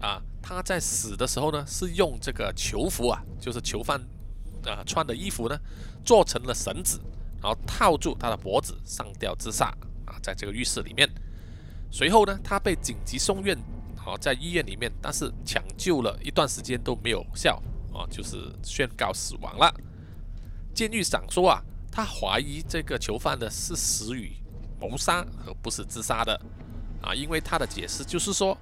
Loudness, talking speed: -27 LUFS, 250 characters per minute